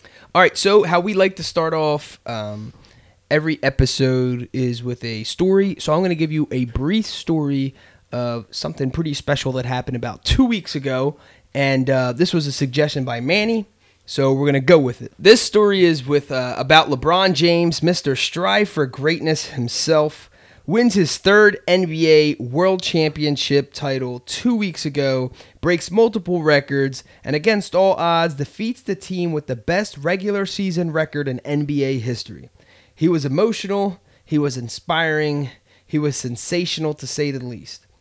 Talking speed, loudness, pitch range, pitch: 165 wpm, -19 LUFS, 130-175 Hz, 150 Hz